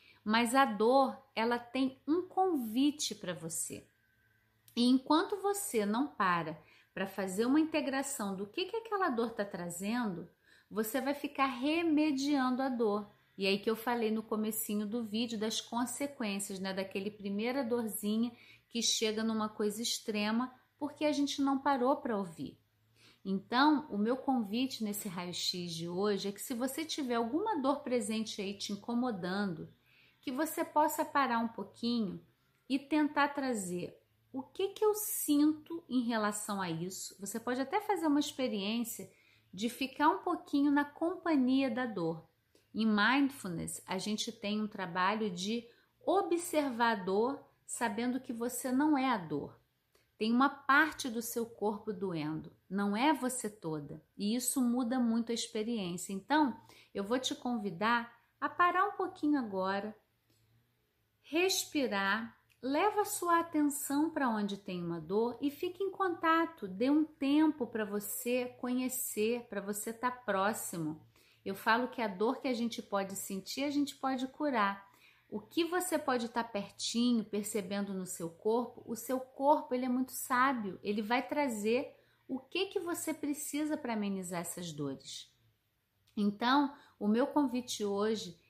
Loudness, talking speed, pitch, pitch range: -34 LUFS, 155 wpm, 235 Hz, 200-280 Hz